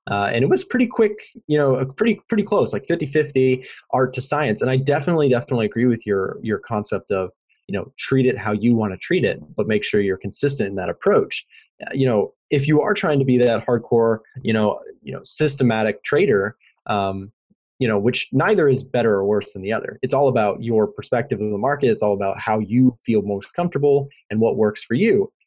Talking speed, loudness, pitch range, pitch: 220 wpm, -20 LUFS, 105-145 Hz, 125 Hz